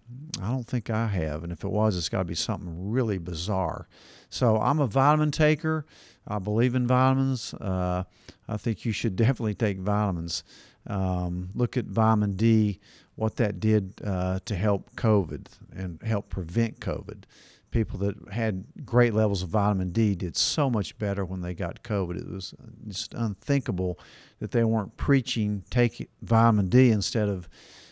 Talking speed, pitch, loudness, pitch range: 170 wpm, 105 Hz, -27 LUFS, 95-120 Hz